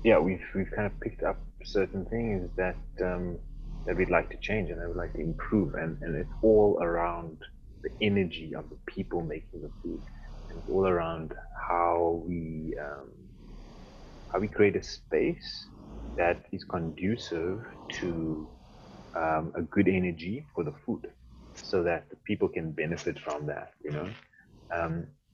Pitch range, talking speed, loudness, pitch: 80-90 Hz, 165 wpm, -31 LUFS, 85 Hz